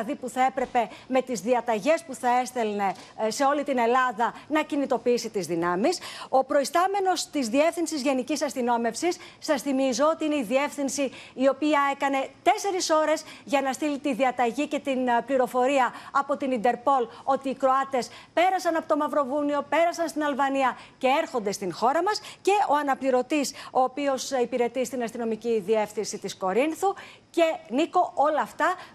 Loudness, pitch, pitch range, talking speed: -26 LUFS, 270 Hz, 245-305 Hz, 155 wpm